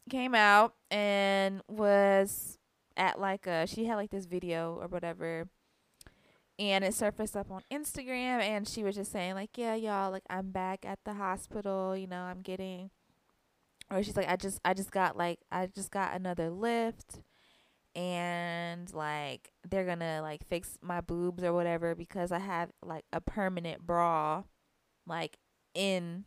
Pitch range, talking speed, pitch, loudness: 175-200 Hz, 165 wpm, 190 Hz, -33 LUFS